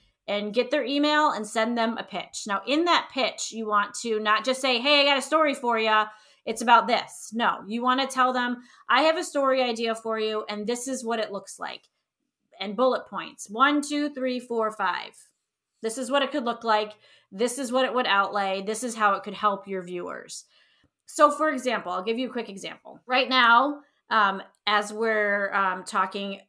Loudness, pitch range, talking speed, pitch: -25 LUFS, 210-260 Hz, 215 wpm, 230 Hz